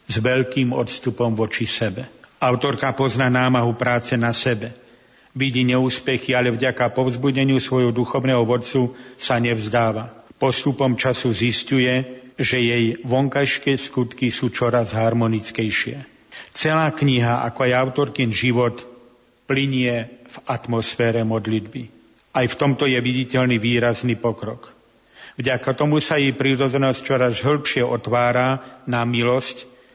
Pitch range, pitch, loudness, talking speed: 120-130 Hz, 125 Hz, -20 LUFS, 115 wpm